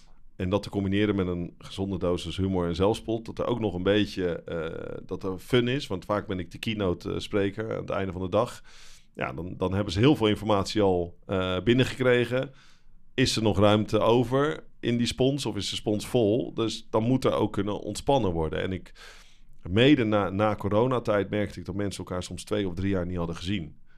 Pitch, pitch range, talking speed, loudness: 100 Hz, 95-115 Hz, 215 wpm, -27 LUFS